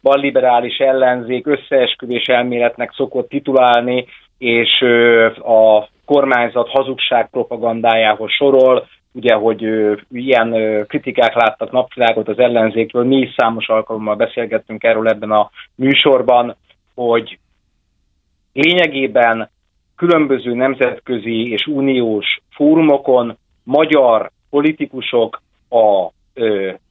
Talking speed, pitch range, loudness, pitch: 85 wpm, 110-130 Hz, -14 LUFS, 120 Hz